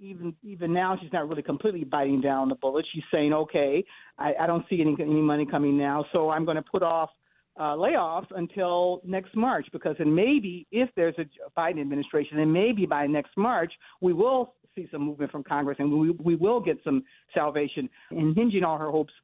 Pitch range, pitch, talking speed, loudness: 150-190 Hz, 165 Hz, 205 wpm, -27 LUFS